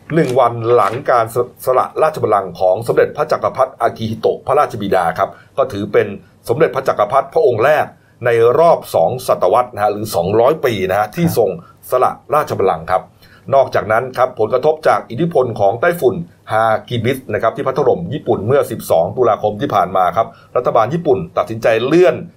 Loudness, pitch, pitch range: -15 LUFS, 115 Hz, 105-130 Hz